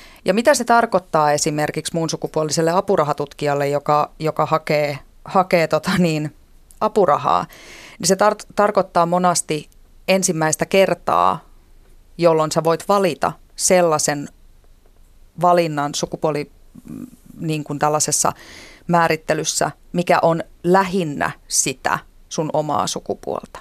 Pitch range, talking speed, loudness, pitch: 150-180 Hz, 100 wpm, -19 LUFS, 160 Hz